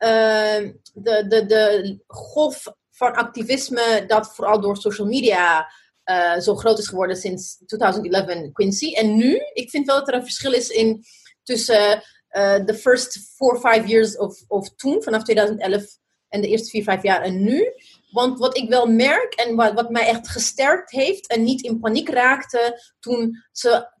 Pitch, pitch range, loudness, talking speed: 225 Hz, 205-245 Hz, -19 LUFS, 180 wpm